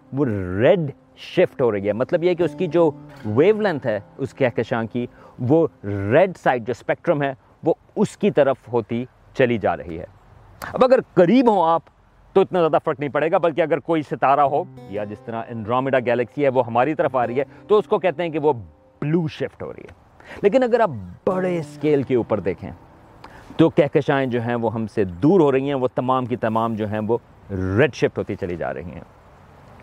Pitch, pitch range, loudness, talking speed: 135 Hz, 115-165 Hz, -21 LUFS, 215 wpm